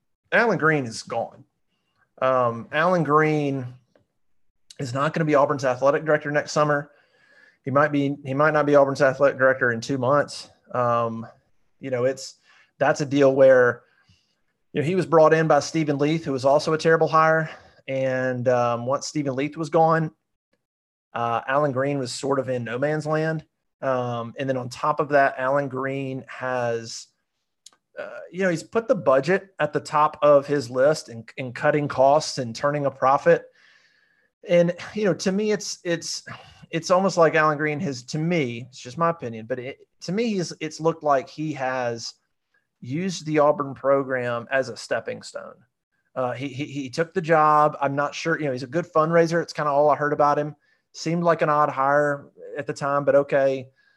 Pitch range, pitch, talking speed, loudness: 130-160 Hz, 145 Hz, 190 wpm, -22 LUFS